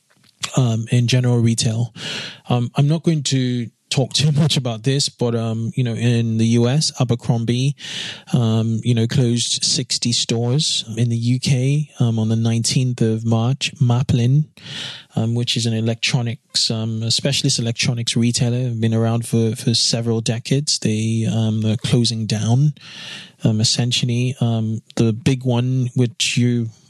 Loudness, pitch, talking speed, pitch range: -19 LUFS, 120 Hz, 150 wpm, 115-135 Hz